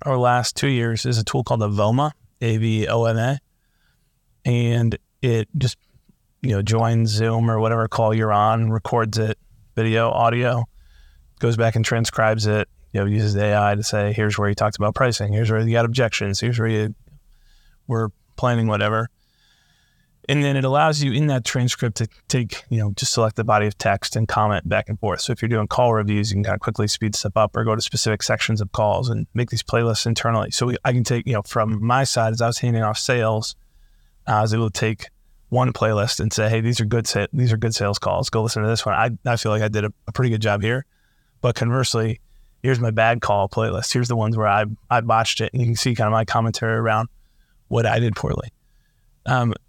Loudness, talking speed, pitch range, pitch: -21 LUFS, 230 wpm, 105-120 Hz, 115 Hz